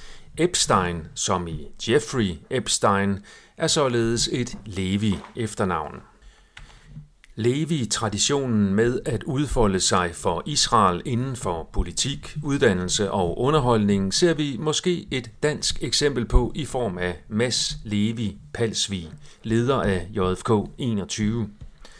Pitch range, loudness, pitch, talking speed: 100-135 Hz, -23 LUFS, 115 Hz, 110 wpm